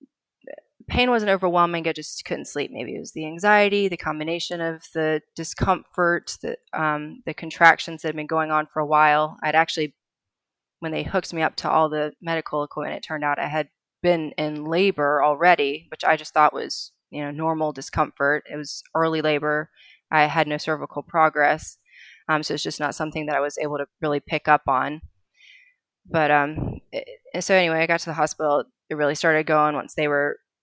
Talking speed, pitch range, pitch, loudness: 195 wpm, 150-165 Hz, 155 Hz, -23 LUFS